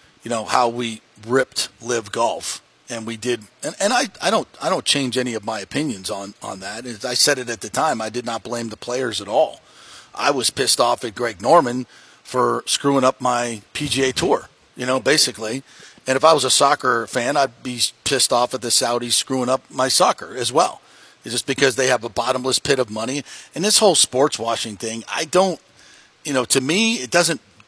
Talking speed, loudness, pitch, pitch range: 215 wpm, -19 LUFS, 125 Hz, 115-135 Hz